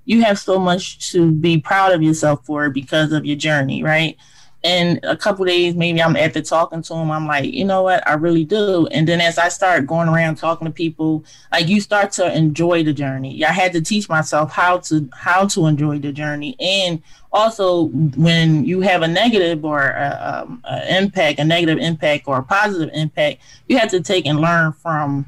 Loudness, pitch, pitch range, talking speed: -17 LUFS, 165 Hz, 155-180 Hz, 210 wpm